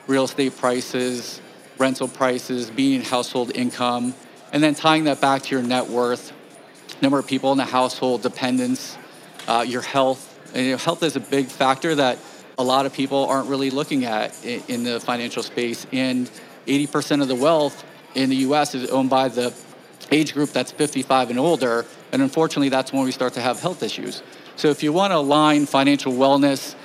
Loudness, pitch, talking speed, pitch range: -21 LUFS, 135 Hz, 185 wpm, 125-140 Hz